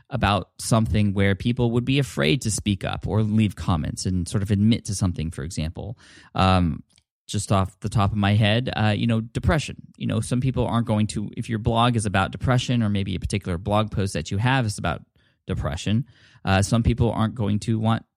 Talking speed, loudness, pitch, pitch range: 215 wpm, -23 LUFS, 105 Hz, 95-115 Hz